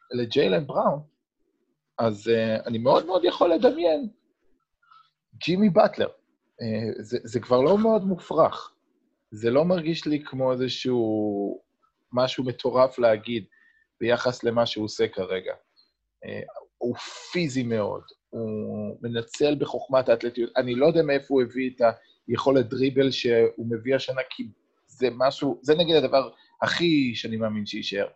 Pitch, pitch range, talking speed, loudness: 130 Hz, 115-170 Hz, 130 wpm, -24 LUFS